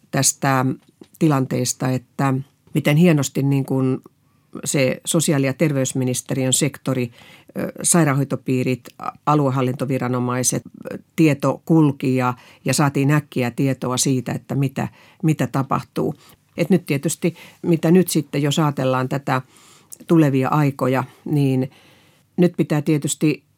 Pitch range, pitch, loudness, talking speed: 130-155 Hz, 140 Hz, -20 LUFS, 105 wpm